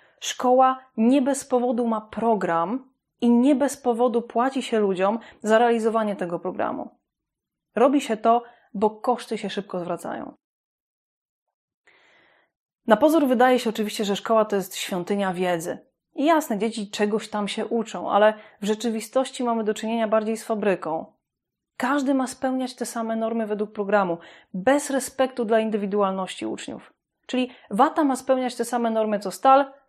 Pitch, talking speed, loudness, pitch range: 225 Hz, 150 wpm, -23 LUFS, 210-255 Hz